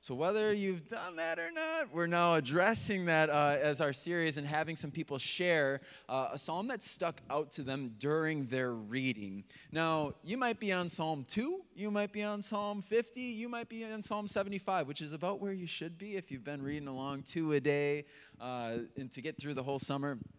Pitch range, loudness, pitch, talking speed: 140-200 Hz, -36 LUFS, 160 Hz, 215 wpm